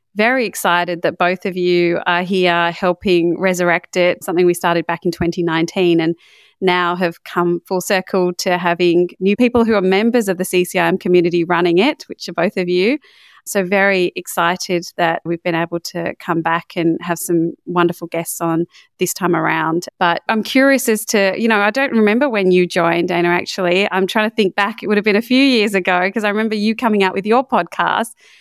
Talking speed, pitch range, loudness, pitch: 205 wpm, 175-205 Hz, -16 LUFS, 180 Hz